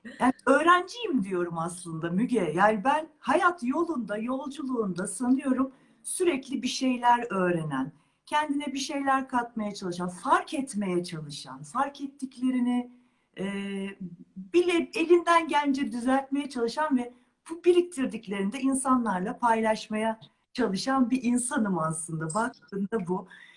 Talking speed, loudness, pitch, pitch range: 105 wpm, -27 LUFS, 245 Hz, 200-275 Hz